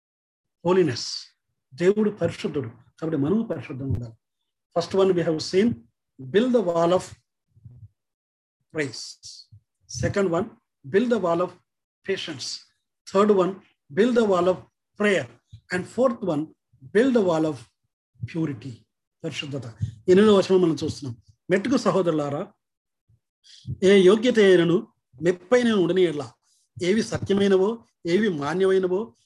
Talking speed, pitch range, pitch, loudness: 115 wpm, 125-195 Hz, 170 Hz, -23 LUFS